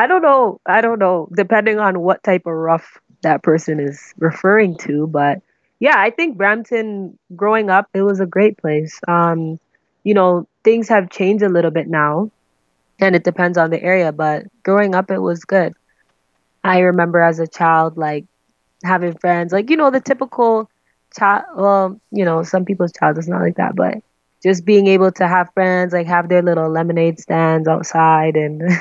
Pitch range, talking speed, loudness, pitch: 165-200 Hz, 185 wpm, -15 LUFS, 180 Hz